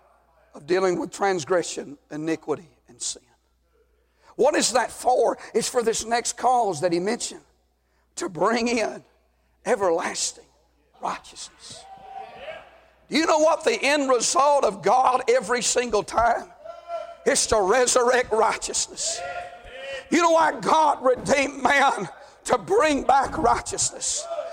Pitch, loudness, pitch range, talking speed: 250 Hz, -22 LUFS, 200-320 Hz, 120 wpm